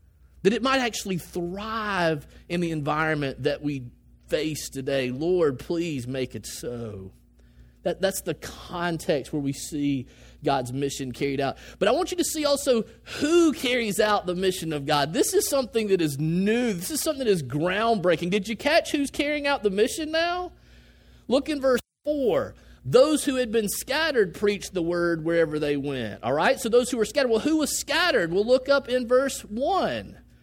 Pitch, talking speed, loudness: 185 Hz, 185 wpm, -25 LUFS